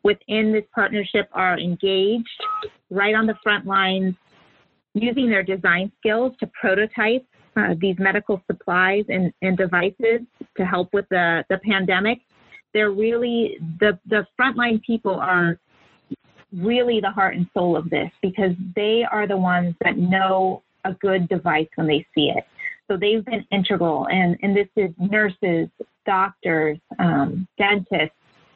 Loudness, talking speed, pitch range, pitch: -21 LUFS, 145 wpm, 180-215 Hz, 195 Hz